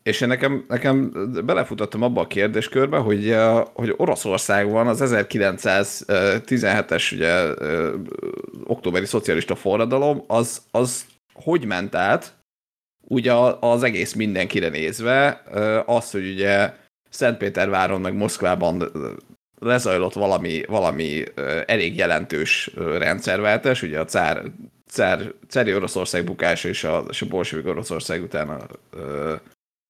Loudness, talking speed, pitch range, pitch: -21 LUFS, 105 wpm, 100-125 Hz, 115 Hz